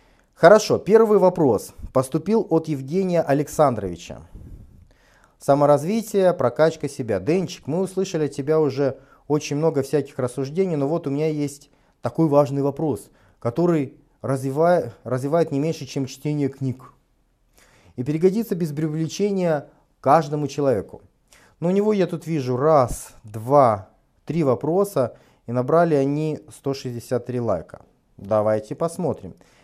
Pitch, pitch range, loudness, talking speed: 145 Hz, 135-165 Hz, -21 LUFS, 120 wpm